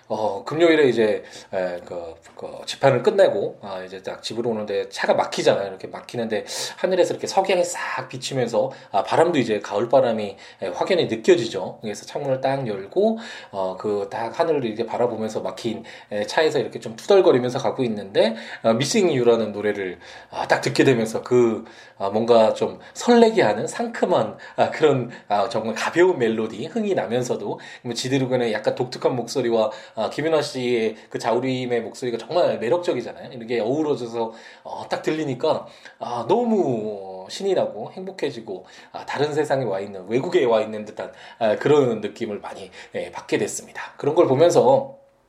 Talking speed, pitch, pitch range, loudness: 355 characters per minute, 125 Hz, 110-175 Hz, -22 LUFS